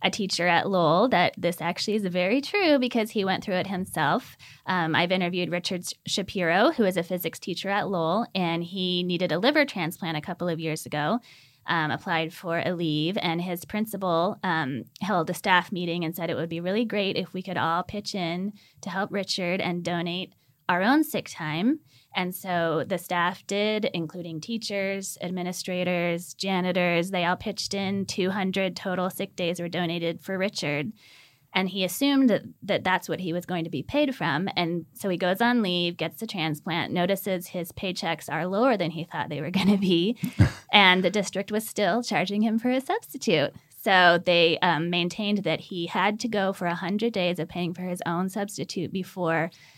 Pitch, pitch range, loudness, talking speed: 180 Hz, 170-200 Hz, -26 LUFS, 195 wpm